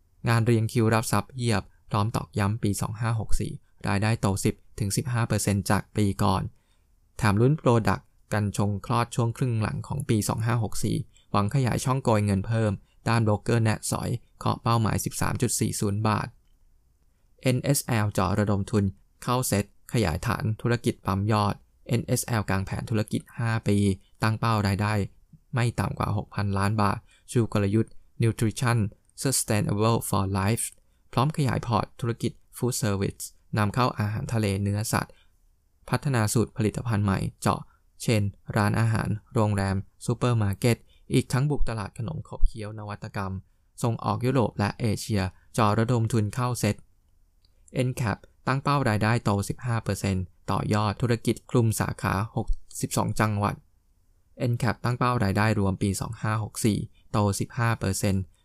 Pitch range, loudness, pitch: 100-120 Hz, -27 LUFS, 105 Hz